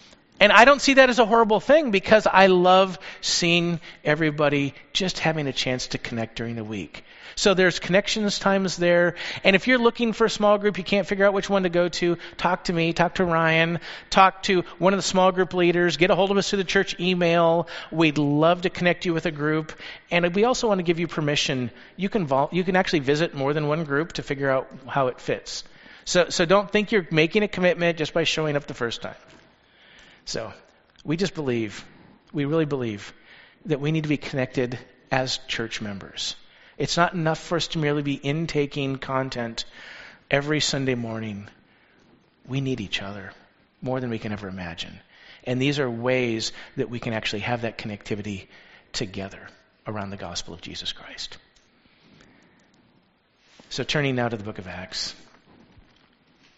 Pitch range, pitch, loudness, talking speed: 125-185 Hz, 155 Hz, -23 LUFS, 190 wpm